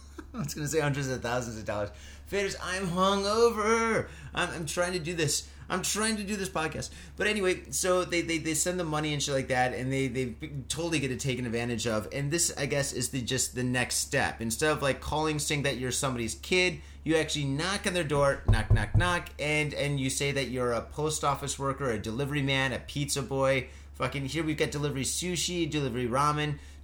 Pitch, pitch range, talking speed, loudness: 140 Hz, 125-165 Hz, 220 wpm, -29 LUFS